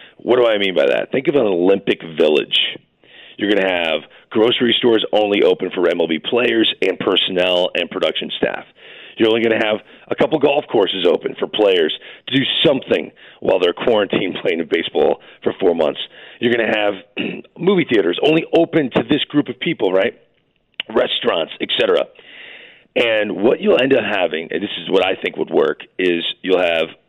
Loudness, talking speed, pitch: -17 LUFS, 185 wpm, 125 Hz